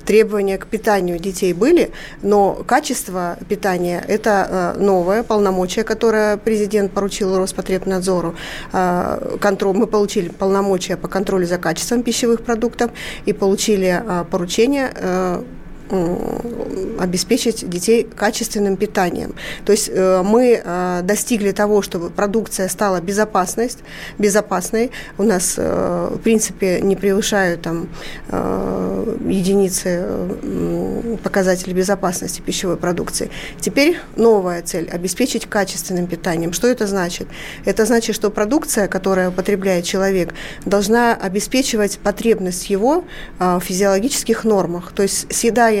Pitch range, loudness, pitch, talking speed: 185-220 Hz, -18 LUFS, 200 Hz, 105 wpm